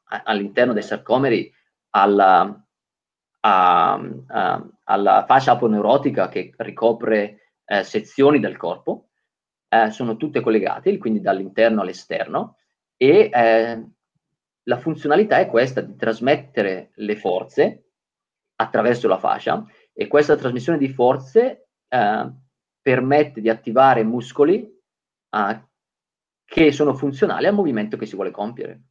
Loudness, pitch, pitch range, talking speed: -19 LUFS, 130 Hz, 115-150 Hz, 110 wpm